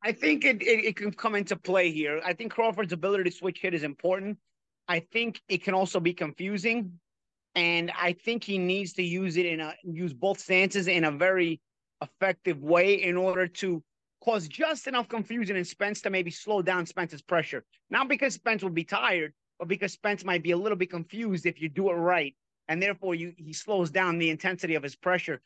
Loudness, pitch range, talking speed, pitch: -28 LUFS, 170-205 Hz, 210 wpm, 185 Hz